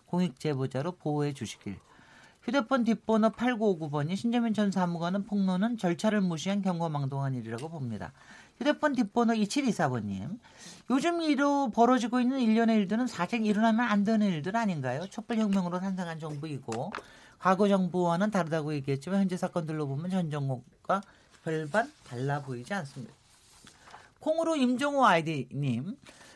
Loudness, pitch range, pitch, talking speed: -29 LUFS, 155-230 Hz, 190 Hz, 340 characters per minute